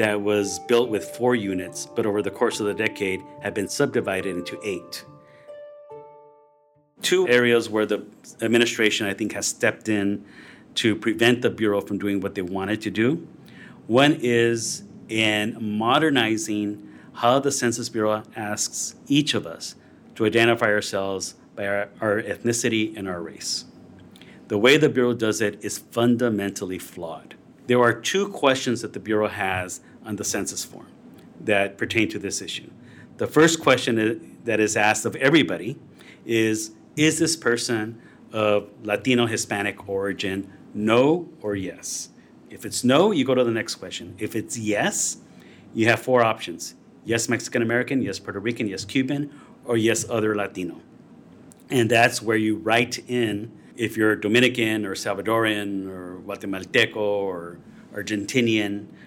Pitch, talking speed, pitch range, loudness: 110 Hz, 150 wpm, 100-120 Hz, -23 LUFS